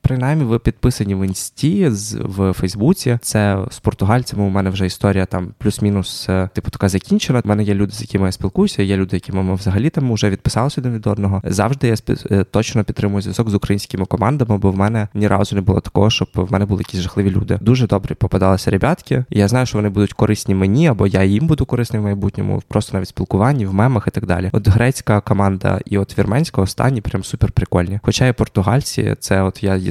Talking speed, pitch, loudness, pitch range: 210 wpm, 105 Hz, -17 LUFS, 95-120 Hz